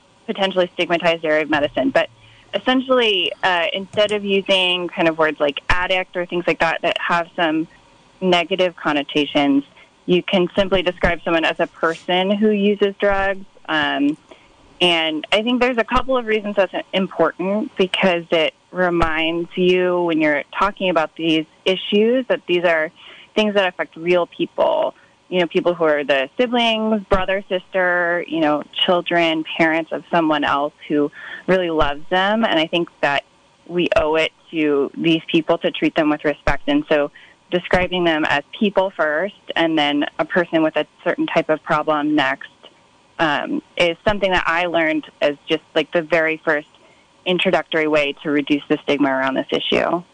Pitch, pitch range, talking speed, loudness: 175 Hz, 160-195 Hz, 165 wpm, -19 LUFS